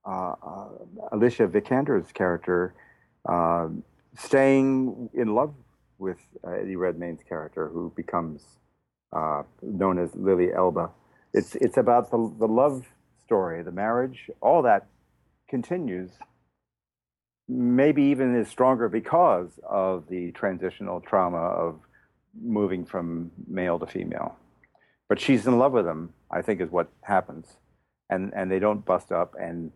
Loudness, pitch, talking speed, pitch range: -26 LUFS, 95 Hz, 135 wpm, 85-120 Hz